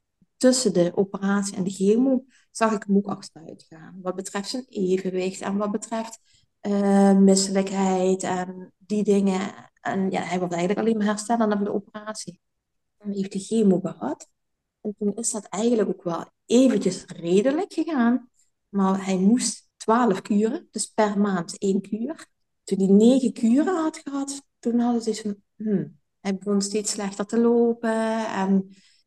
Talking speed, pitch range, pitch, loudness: 165 wpm, 195-225 Hz, 205 Hz, -23 LUFS